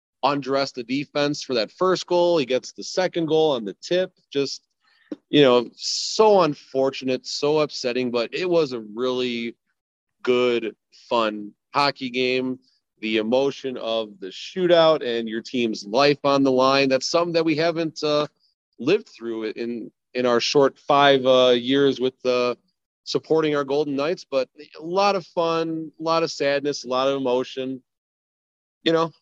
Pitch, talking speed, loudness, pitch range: 135 Hz, 160 wpm, -22 LUFS, 125-155 Hz